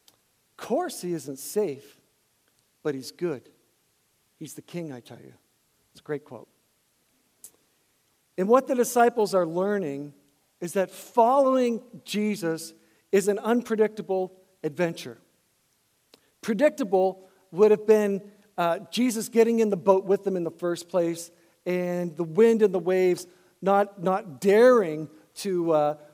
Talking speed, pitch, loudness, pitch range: 135 wpm, 185 Hz, -25 LUFS, 165-210 Hz